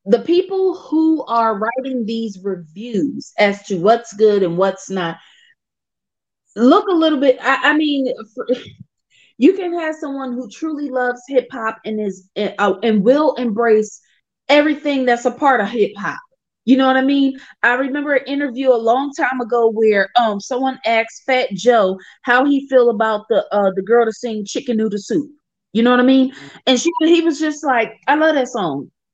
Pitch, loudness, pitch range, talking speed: 250 Hz, -17 LUFS, 220-280 Hz, 185 wpm